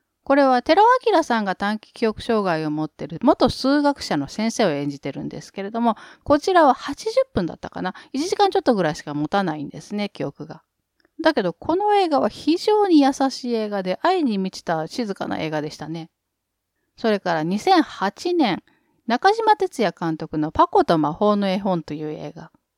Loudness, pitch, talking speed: -21 LUFS, 225 Hz, 335 characters per minute